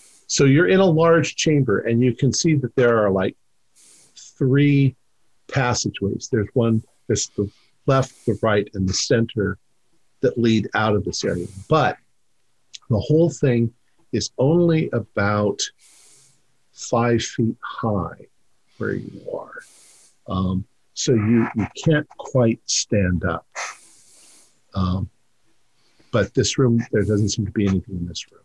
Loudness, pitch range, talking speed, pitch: -21 LUFS, 100-135 Hz, 140 wpm, 115 Hz